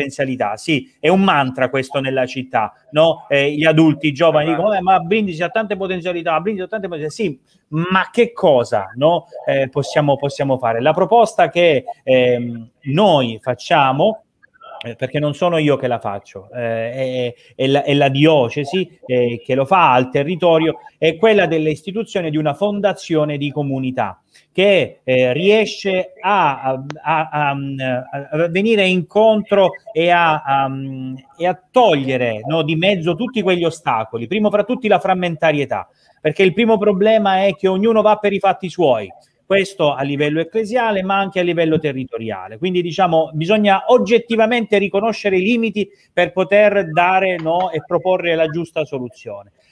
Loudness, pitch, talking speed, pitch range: -16 LUFS, 165 Hz, 160 wpm, 140-195 Hz